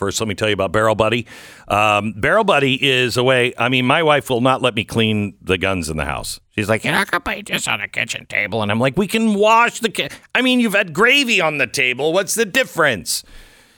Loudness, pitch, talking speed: -17 LUFS, 125 Hz, 255 wpm